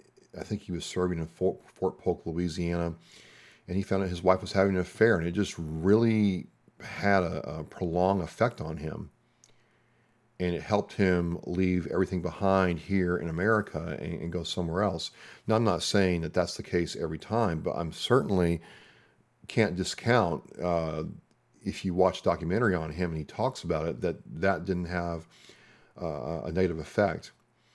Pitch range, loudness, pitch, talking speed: 85-100 Hz, -29 LUFS, 90 Hz, 175 wpm